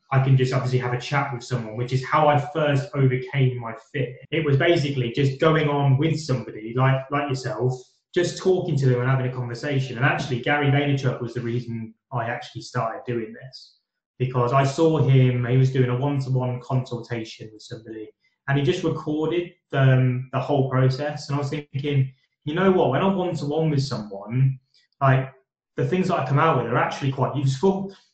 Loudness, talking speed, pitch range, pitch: -23 LUFS, 195 wpm, 125-145 Hz, 135 Hz